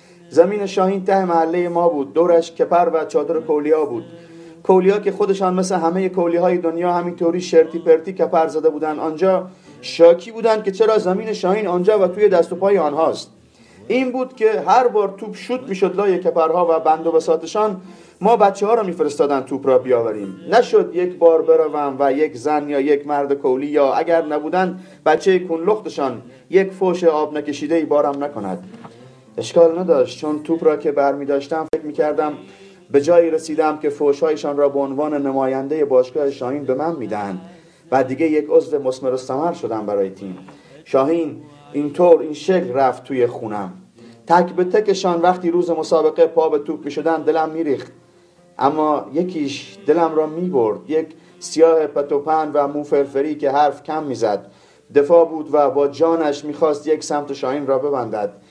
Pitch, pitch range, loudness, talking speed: 165 Hz, 145-180 Hz, -18 LUFS, 175 wpm